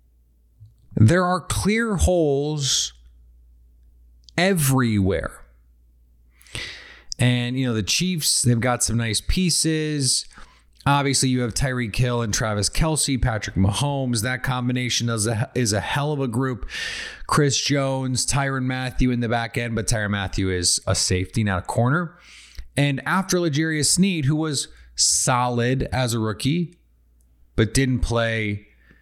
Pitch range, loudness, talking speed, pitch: 95-140 Hz, -21 LUFS, 135 wpm, 120 Hz